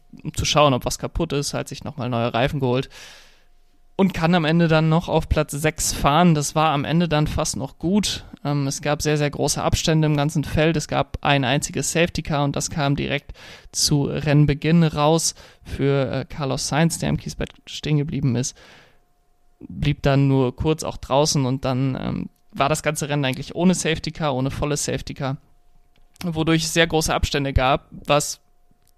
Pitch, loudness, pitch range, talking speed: 145 Hz, -21 LUFS, 135-160 Hz, 190 wpm